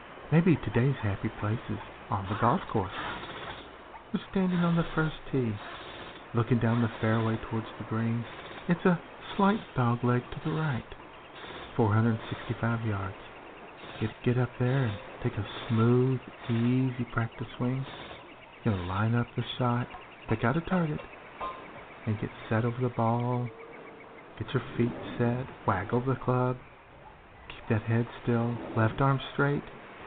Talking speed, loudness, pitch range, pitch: 145 wpm, -30 LUFS, 115-130 Hz, 120 Hz